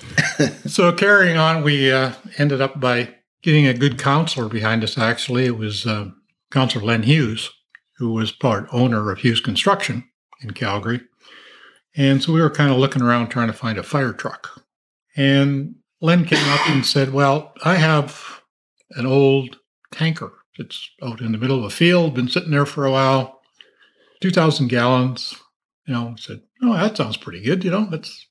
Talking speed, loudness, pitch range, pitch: 180 wpm, -18 LUFS, 120-155 Hz, 135 Hz